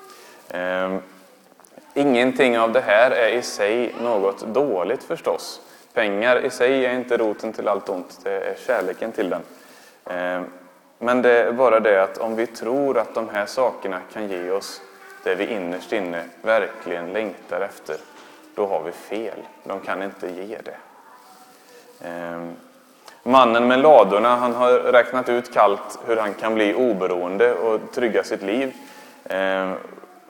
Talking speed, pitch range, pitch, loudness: 155 wpm, 100-135 Hz, 120 Hz, -21 LUFS